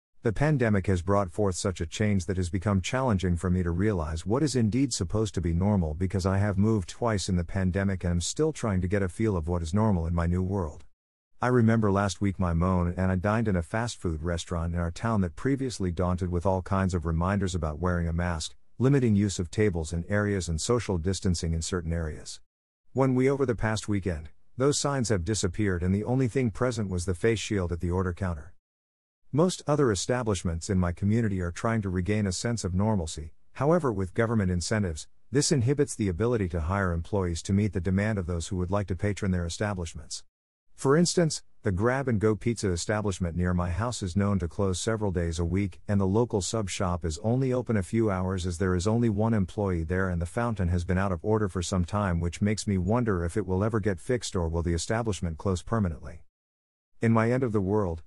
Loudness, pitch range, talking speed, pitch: -28 LUFS, 90-110 Hz, 225 wpm, 95 Hz